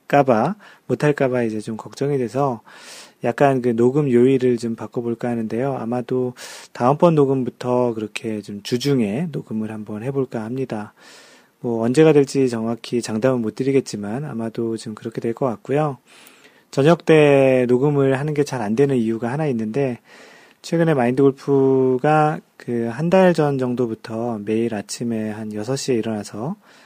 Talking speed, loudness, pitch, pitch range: 315 characters per minute, -20 LUFS, 125 Hz, 115-140 Hz